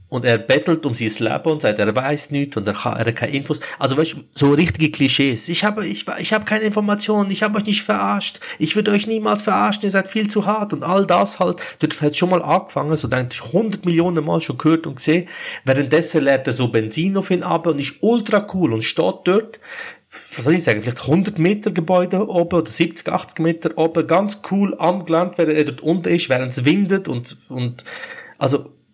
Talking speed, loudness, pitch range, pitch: 220 wpm, -19 LUFS, 140-195 Hz, 165 Hz